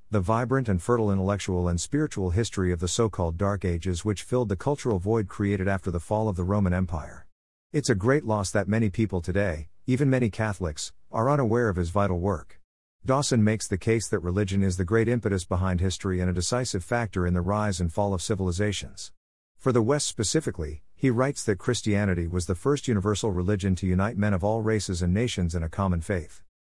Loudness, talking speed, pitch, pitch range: -26 LUFS, 205 wpm, 100 Hz, 90-110 Hz